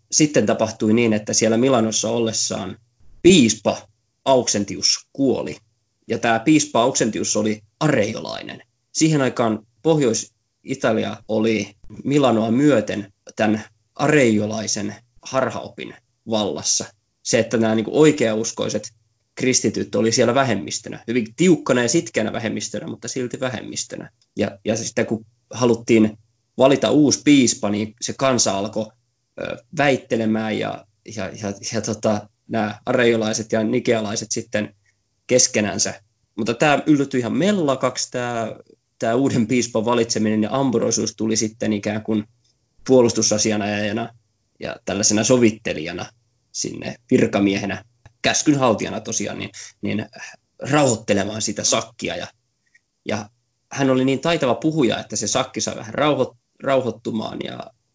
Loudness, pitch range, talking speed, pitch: -20 LUFS, 110-125 Hz, 115 wpm, 115 Hz